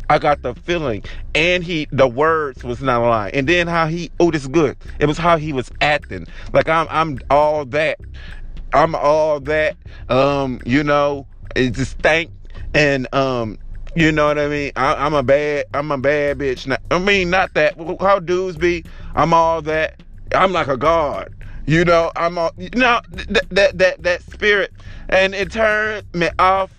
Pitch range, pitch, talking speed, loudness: 135-175 Hz, 150 Hz, 195 wpm, -17 LUFS